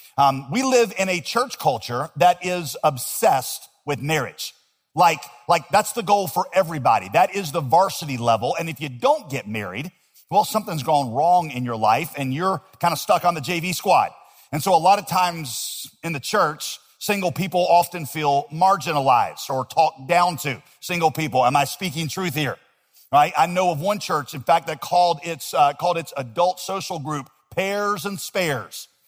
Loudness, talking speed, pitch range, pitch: -21 LUFS, 190 wpm, 140-185 Hz, 170 Hz